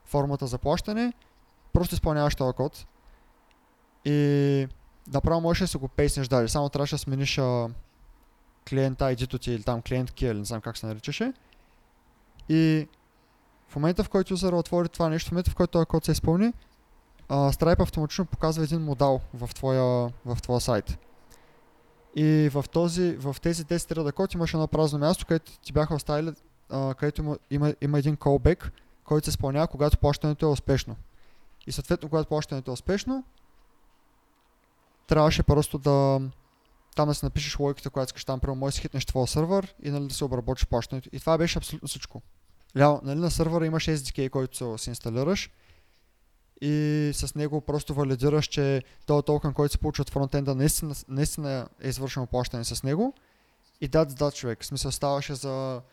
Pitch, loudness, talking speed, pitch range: 145 Hz, -27 LUFS, 175 wpm, 135-155 Hz